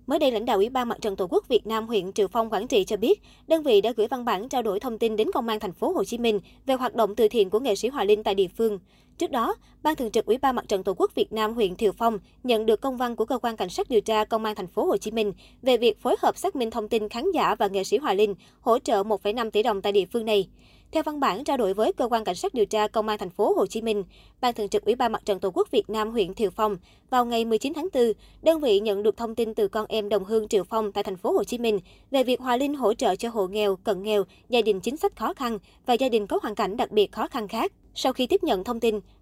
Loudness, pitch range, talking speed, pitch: -25 LUFS, 210-270 Hz, 305 wpm, 225 Hz